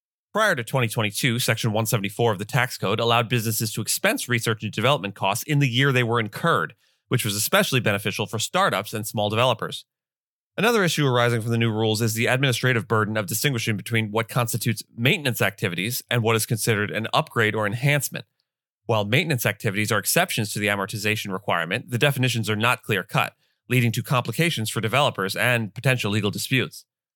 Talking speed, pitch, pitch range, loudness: 180 wpm, 115 Hz, 110-130 Hz, -23 LUFS